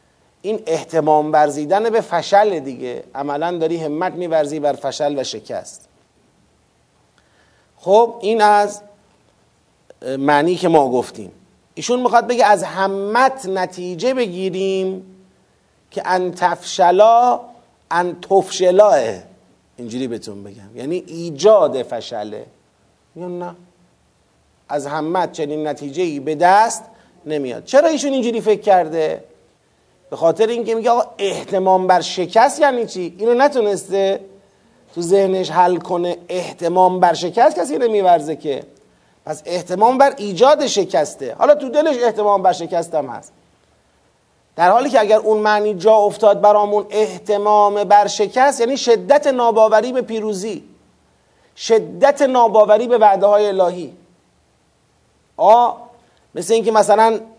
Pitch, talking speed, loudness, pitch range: 195 Hz, 120 wpm, -16 LUFS, 170-225 Hz